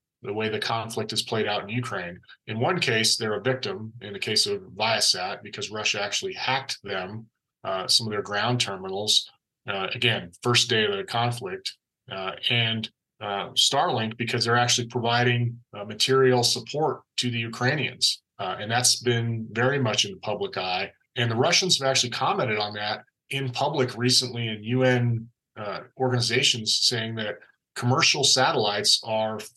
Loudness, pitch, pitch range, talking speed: -24 LUFS, 120 Hz, 110-125 Hz, 165 wpm